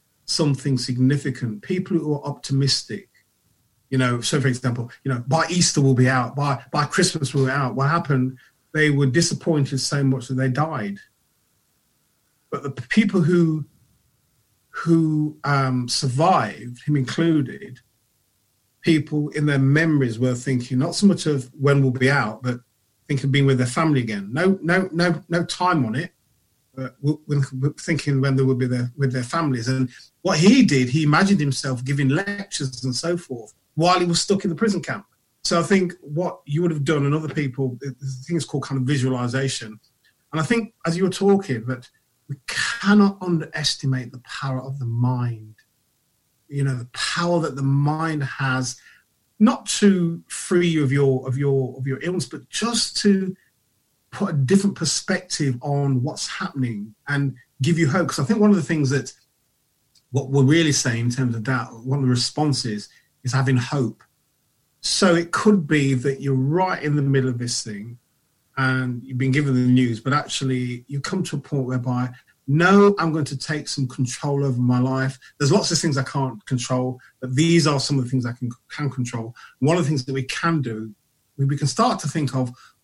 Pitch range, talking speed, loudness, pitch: 130-160 Hz, 190 wpm, -21 LUFS, 140 Hz